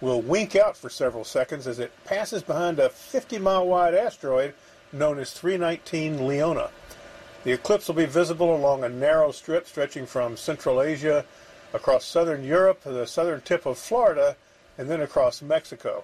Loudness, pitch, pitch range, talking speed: -25 LUFS, 170 Hz, 145-210 Hz, 170 wpm